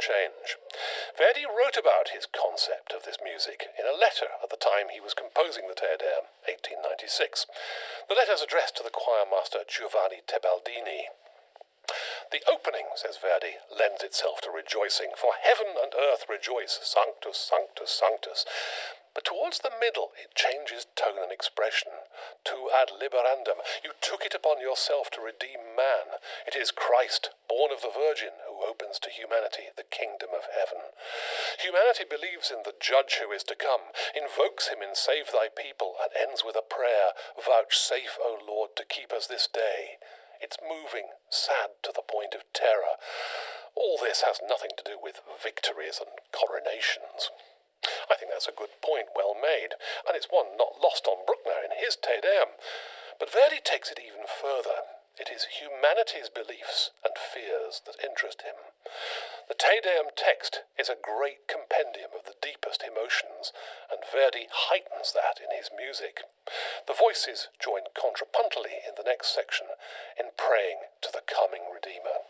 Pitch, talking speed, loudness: 155 Hz, 165 wpm, -29 LUFS